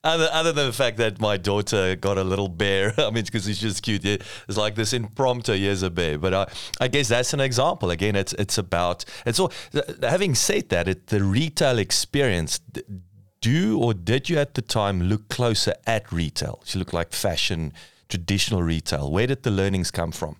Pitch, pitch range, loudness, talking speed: 105 Hz, 95-120 Hz, -23 LUFS, 200 wpm